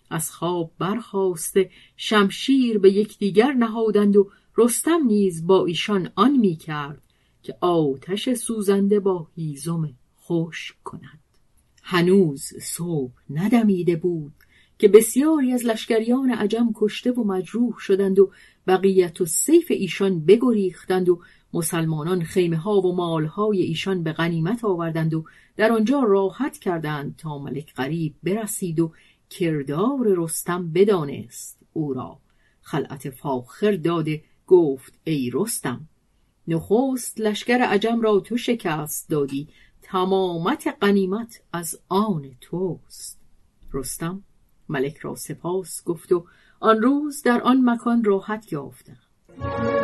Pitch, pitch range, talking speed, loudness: 185 Hz, 160-215 Hz, 115 wpm, -22 LUFS